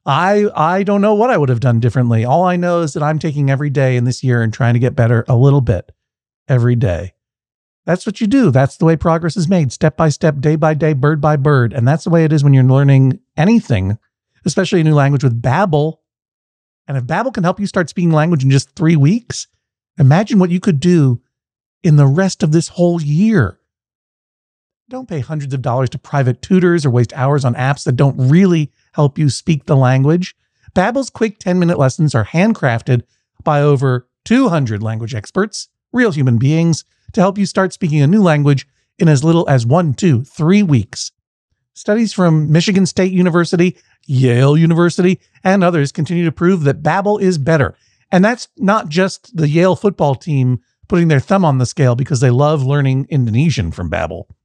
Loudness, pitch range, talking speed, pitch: -14 LUFS, 130-180 Hz, 200 wpm, 150 Hz